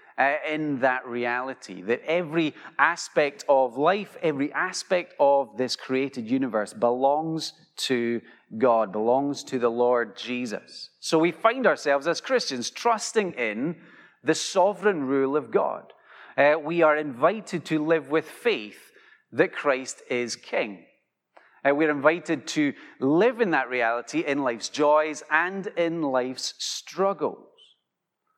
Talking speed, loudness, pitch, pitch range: 135 wpm, -25 LUFS, 155 Hz, 130-175 Hz